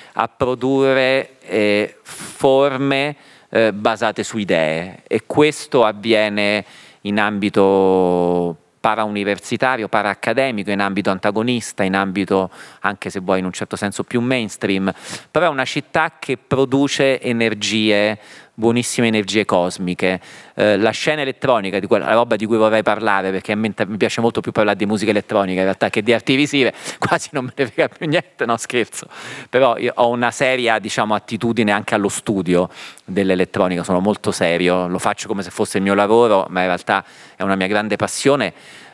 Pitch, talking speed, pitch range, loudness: 110 Hz, 160 wpm, 100-125 Hz, -18 LUFS